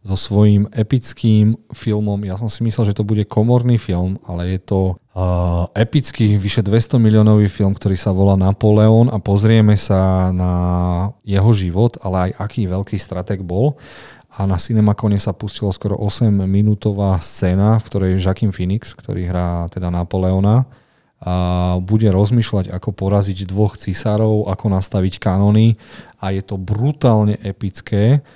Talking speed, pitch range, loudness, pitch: 150 wpm, 95-110 Hz, -16 LUFS, 100 Hz